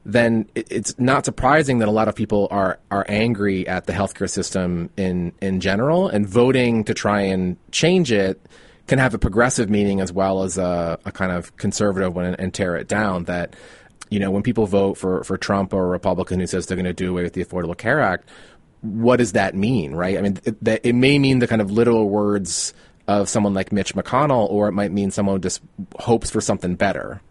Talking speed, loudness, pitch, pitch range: 215 wpm, -20 LUFS, 100 Hz, 95-110 Hz